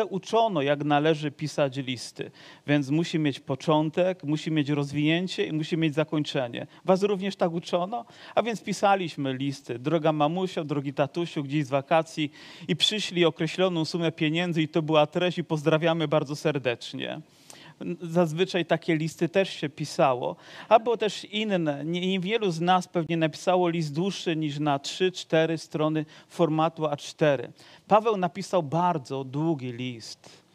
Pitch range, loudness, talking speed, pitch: 150-180 Hz, -26 LUFS, 140 wpm, 160 Hz